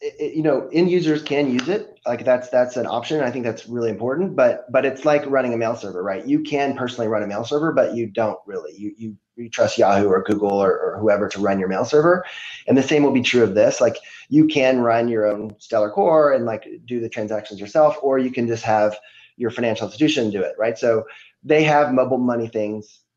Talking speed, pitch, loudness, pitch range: 240 wpm, 120 Hz, -20 LUFS, 110-145 Hz